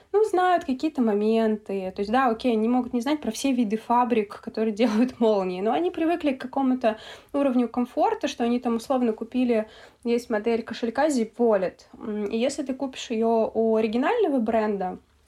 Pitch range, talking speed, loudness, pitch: 220-265 Hz, 170 wpm, -25 LUFS, 235 Hz